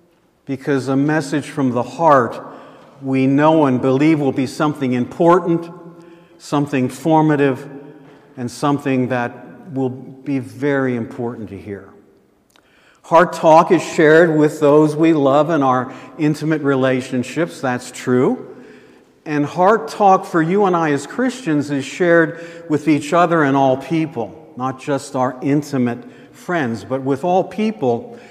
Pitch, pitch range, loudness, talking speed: 145 Hz, 130-165 Hz, -17 LUFS, 140 wpm